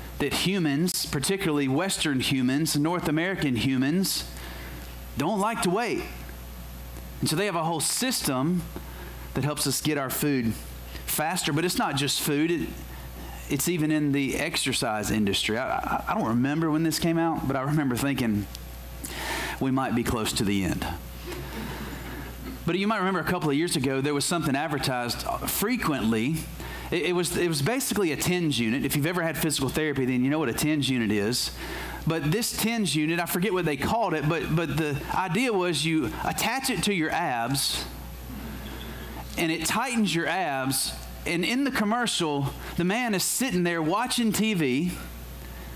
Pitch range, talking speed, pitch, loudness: 105-170 Hz, 170 wpm, 145 Hz, -26 LUFS